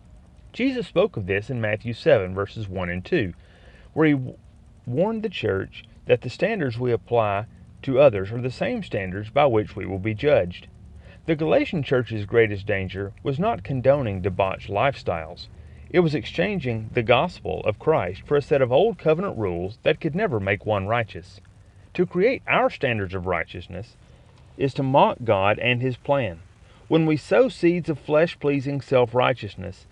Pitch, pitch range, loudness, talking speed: 115 Hz, 100-150 Hz, -23 LUFS, 170 wpm